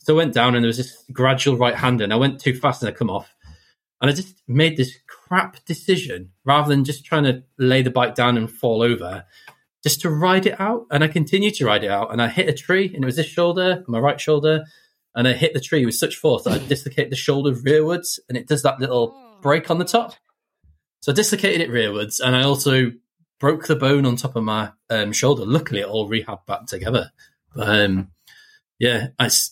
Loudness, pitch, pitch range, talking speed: -20 LUFS, 135 Hz, 120-155 Hz, 230 wpm